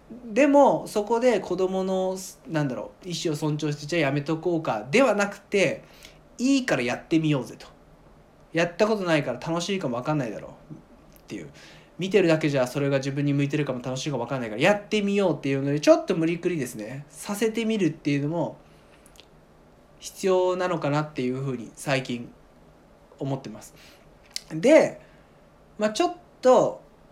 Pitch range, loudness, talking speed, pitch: 140-200 Hz, -25 LUFS, 365 characters per minute, 165 Hz